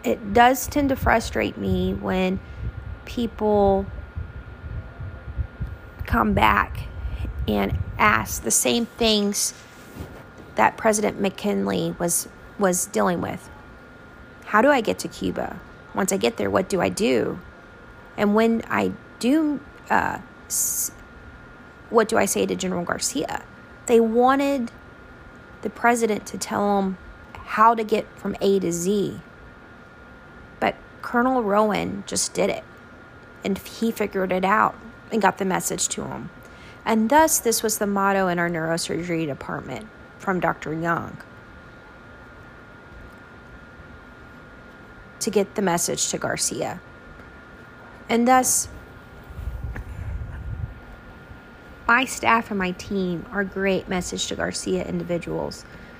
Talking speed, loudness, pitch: 120 wpm, -23 LUFS, 195 Hz